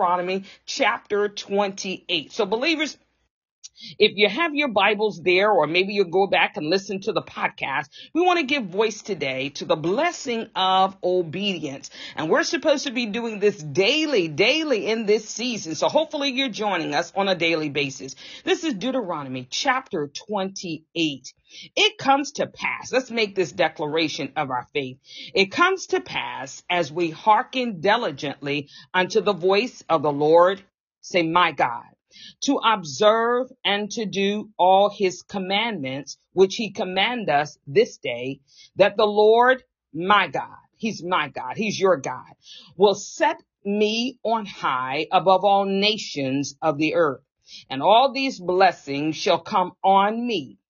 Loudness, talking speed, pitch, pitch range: -22 LUFS, 155 wpm, 195 Hz, 165-225 Hz